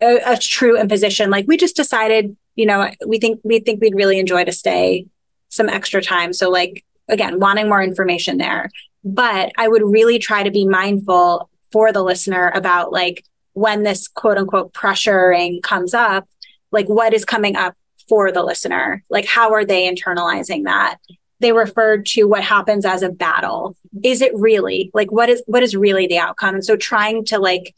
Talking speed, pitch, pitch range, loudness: 190 wpm, 205 Hz, 185-225 Hz, -15 LUFS